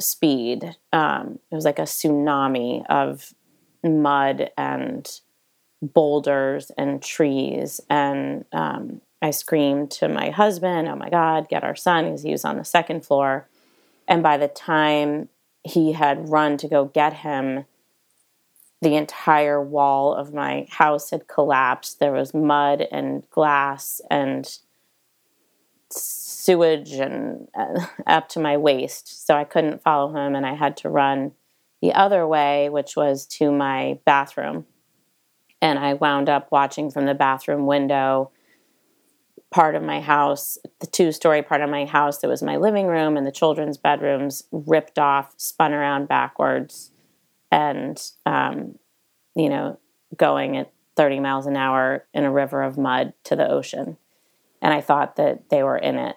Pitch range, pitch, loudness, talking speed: 140-155 Hz, 145 Hz, -21 LUFS, 155 wpm